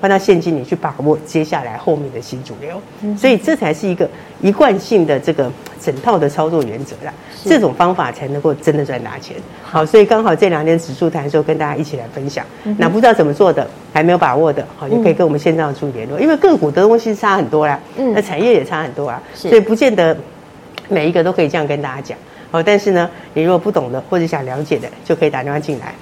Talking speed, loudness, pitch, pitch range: 370 characters per minute, -15 LUFS, 165 Hz, 150-200 Hz